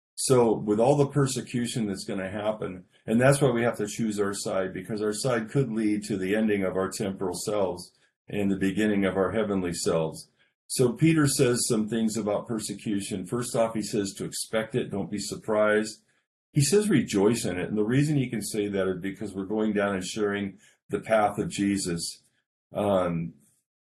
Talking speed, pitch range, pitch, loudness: 195 wpm, 100-115 Hz, 105 Hz, -27 LUFS